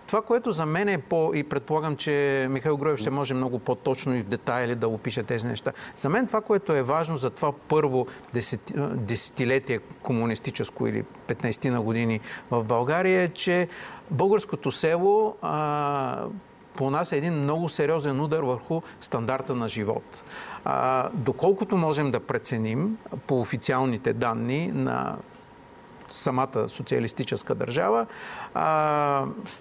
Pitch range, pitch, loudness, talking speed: 125-160 Hz, 140 Hz, -26 LUFS, 135 wpm